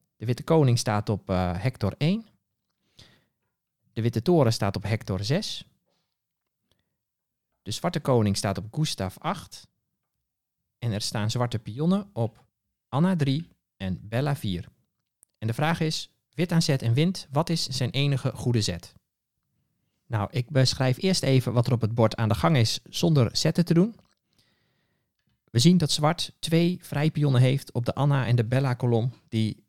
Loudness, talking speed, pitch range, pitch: -25 LUFS, 165 wpm, 110-155 Hz, 130 Hz